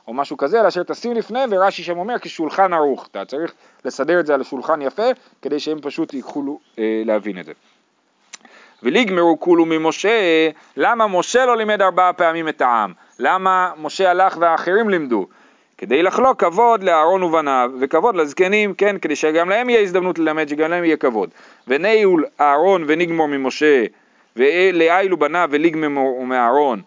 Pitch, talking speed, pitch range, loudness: 165 Hz, 155 wpm, 145-190 Hz, -17 LUFS